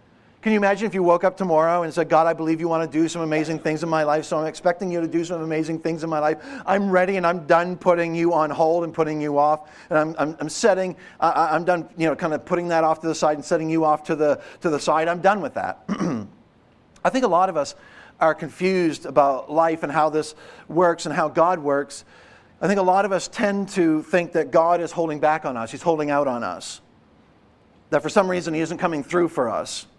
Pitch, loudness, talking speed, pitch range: 165 Hz, -22 LUFS, 255 wpm, 155-175 Hz